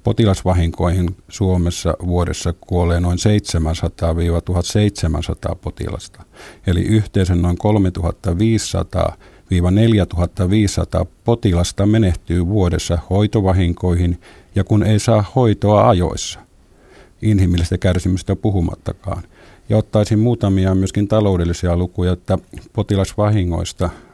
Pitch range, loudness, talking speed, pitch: 85-105 Hz, -17 LUFS, 80 wpm, 95 Hz